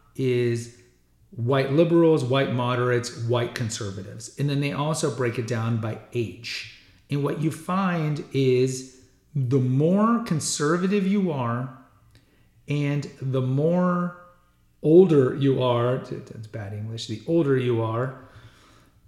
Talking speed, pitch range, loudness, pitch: 125 wpm, 115-150 Hz, -24 LUFS, 130 Hz